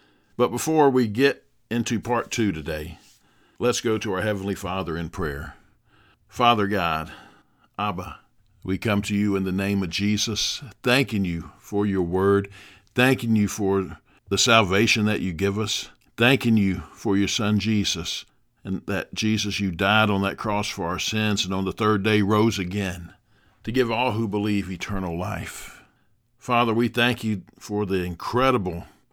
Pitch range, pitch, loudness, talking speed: 95-110 Hz, 105 Hz, -23 LUFS, 165 wpm